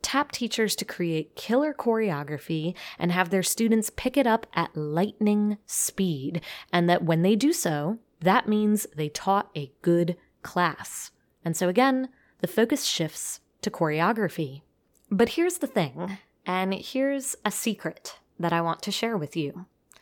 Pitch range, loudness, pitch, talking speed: 170-225 Hz, -26 LUFS, 195 Hz, 155 wpm